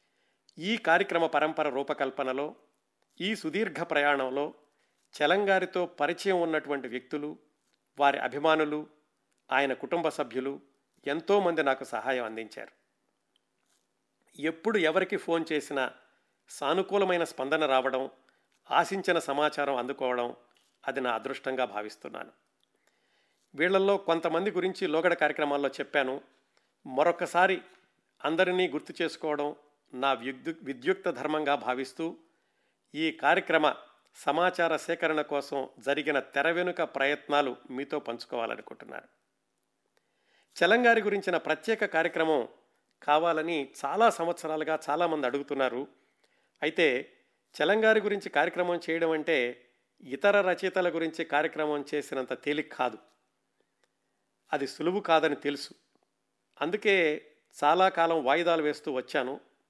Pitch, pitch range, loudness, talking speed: 155 Hz, 140-175 Hz, -29 LUFS, 90 wpm